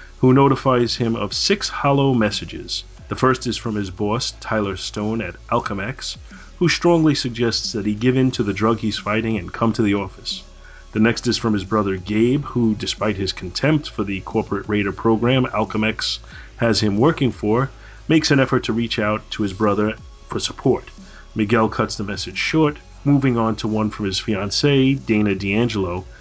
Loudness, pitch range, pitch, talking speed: -20 LUFS, 105-125 Hz, 110 Hz, 185 wpm